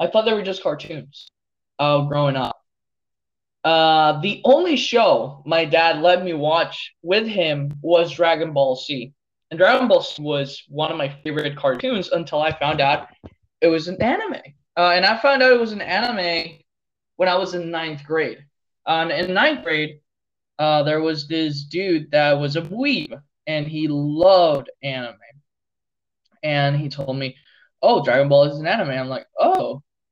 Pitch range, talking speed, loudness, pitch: 140-180 Hz, 175 wpm, -19 LUFS, 155 Hz